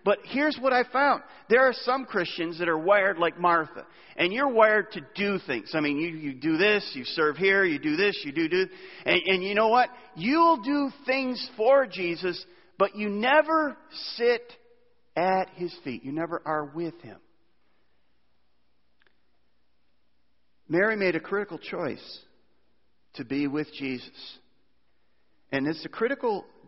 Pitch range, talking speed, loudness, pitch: 155-255 Hz, 160 wpm, -26 LUFS, 195 Hz